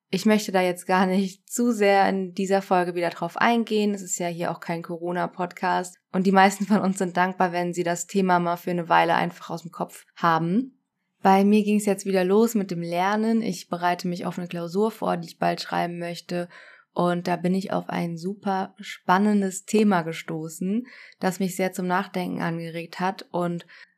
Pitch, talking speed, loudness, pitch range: 185 Hz, 205 wpm, -24 LUFS, 175-195 Hz